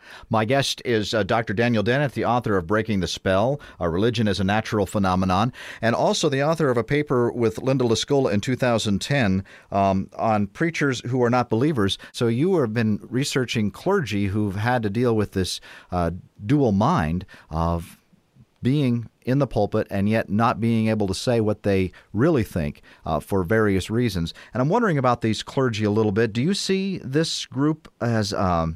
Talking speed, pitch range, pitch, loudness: 190 wpm, 100-125 Hz, 110 Hz, -23 LUFS